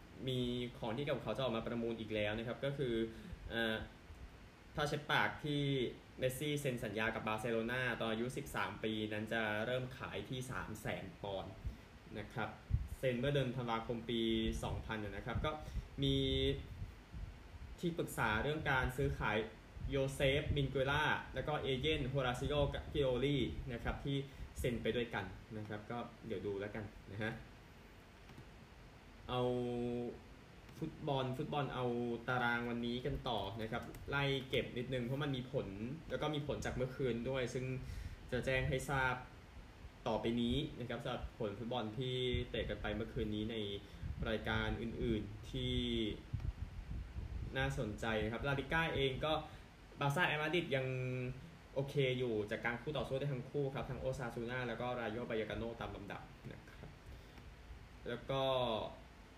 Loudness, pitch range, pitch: -40 LUFS, 110-130 Hz, 120 Hz